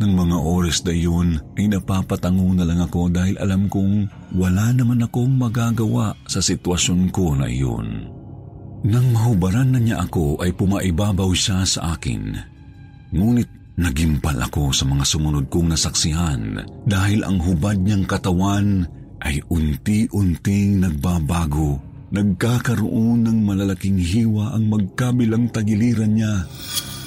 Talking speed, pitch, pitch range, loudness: 125 wpm, 95 Hz, 85-110 Hz, -20 LUFS